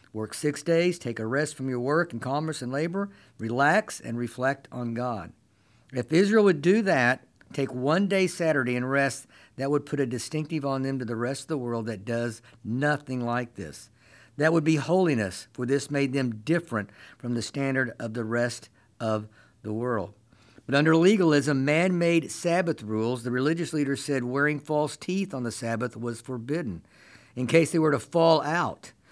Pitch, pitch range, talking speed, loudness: 135 Hz, 120-155 Hz, 190 wpm, -26 LUFS